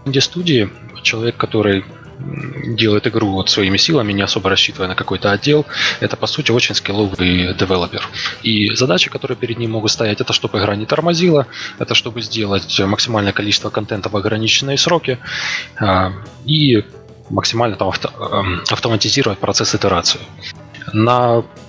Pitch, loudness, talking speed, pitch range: 110 Hz, -16 LUFS, 140 wpm, 100-120 Hz